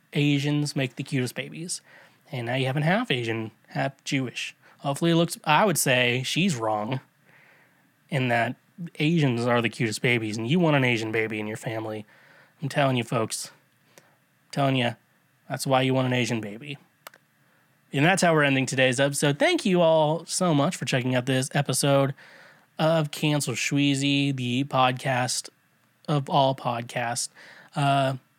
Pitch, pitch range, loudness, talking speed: 140 Hz, 125-150 Hz, -25 LUFS, 165 wpm